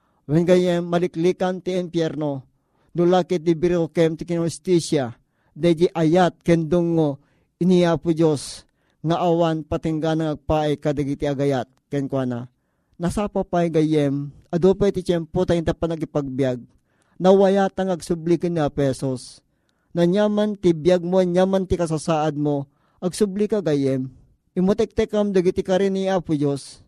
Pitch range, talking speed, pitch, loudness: 145-180 Hz, 130 wpm, 170 Hz, -21 LUFS